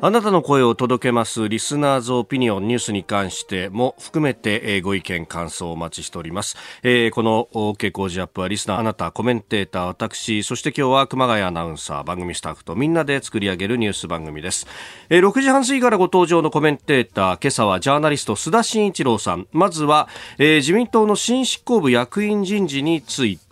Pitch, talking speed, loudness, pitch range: 120 Hz, 430 characters per minute, -19 LUFS, 100-150 Hz